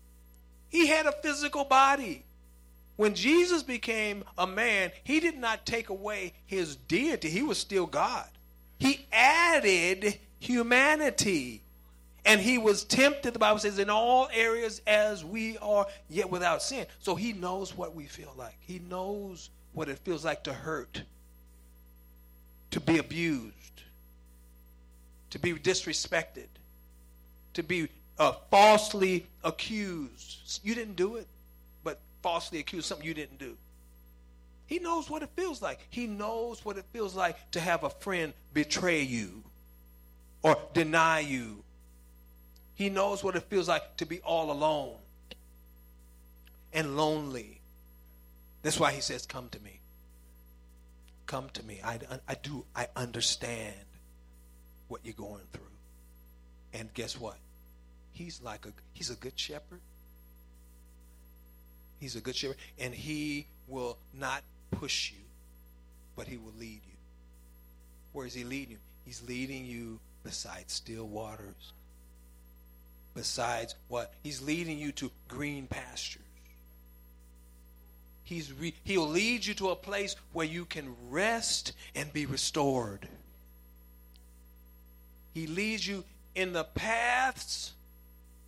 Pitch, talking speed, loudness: 120 Hz, 130 wpm, -30 LUFS